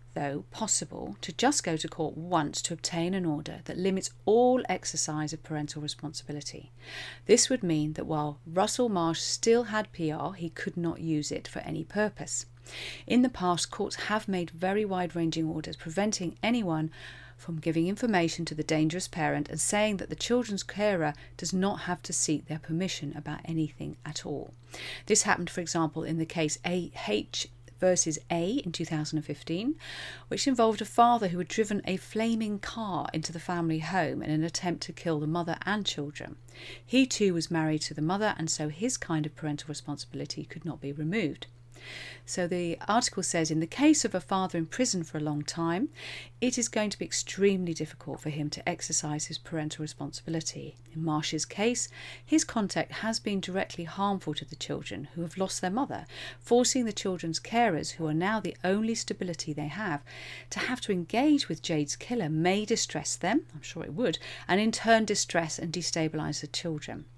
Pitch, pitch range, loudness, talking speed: 165 Hz, 150-195 Hz, -30 LUFS, 185 wpm